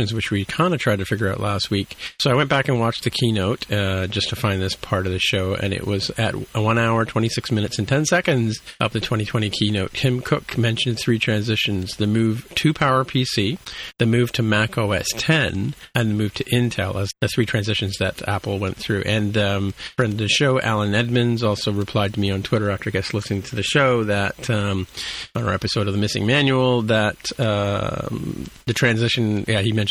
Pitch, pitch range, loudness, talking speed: 110 Hz, 100-120 Hz, -21 LUFS, 215 wpm